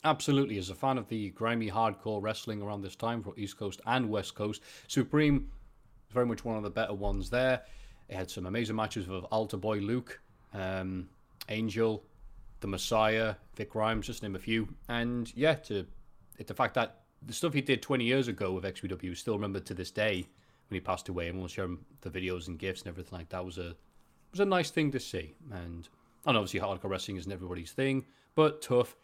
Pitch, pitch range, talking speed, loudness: 105 Hz, 95-120 Hz, 215 wpm, -33 LUFS